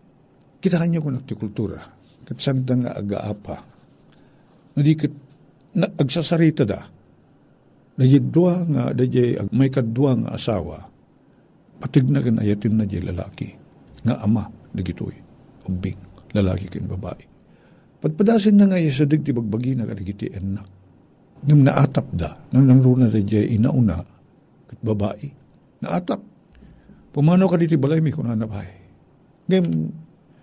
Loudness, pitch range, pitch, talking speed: -20 LUFS, 105-150 Hz, 130 Hz, 115 wpm